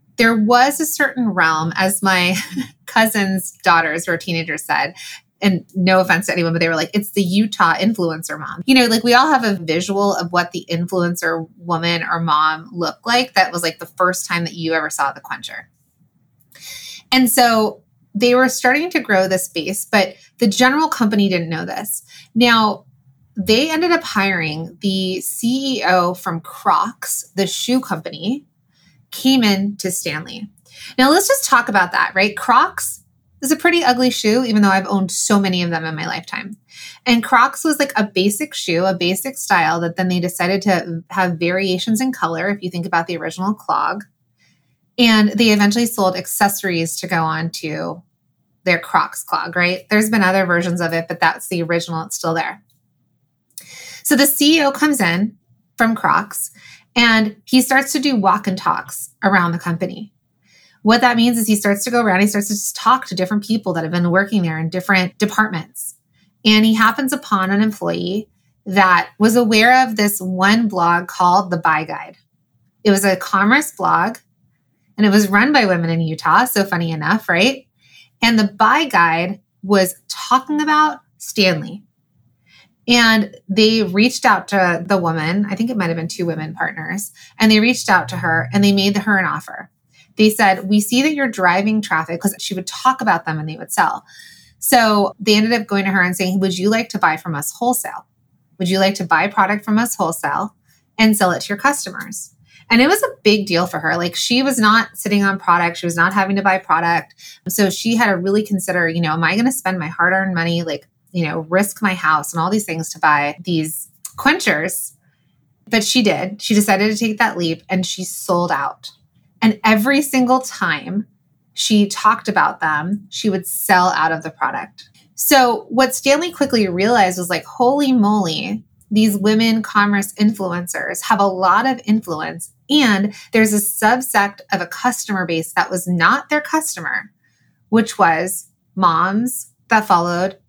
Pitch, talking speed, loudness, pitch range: 195 Hz, 190 wpm, -16 LUFS, 175-225 Hz